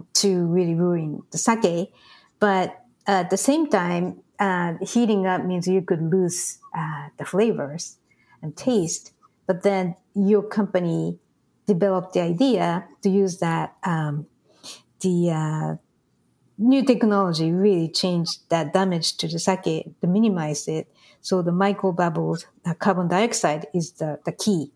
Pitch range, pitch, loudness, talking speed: 165-200 Hz, 180 Hz, -23 LUFS, 145 wpm